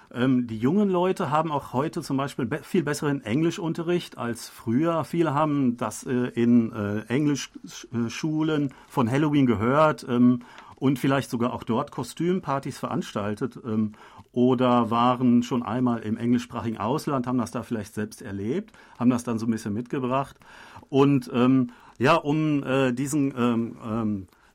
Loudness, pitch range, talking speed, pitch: -25 LUFS, 120-145 Hz, 135 wpm, 125 Hz